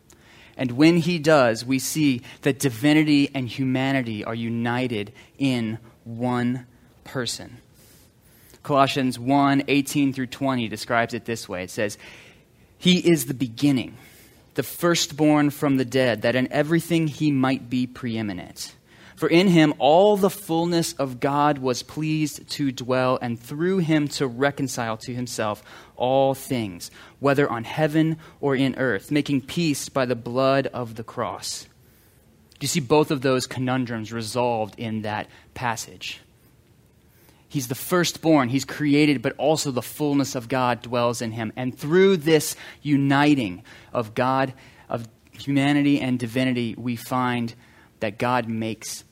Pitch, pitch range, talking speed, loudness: 130 Hz, 120-145 Hz, 140 wpm, -23 LUFS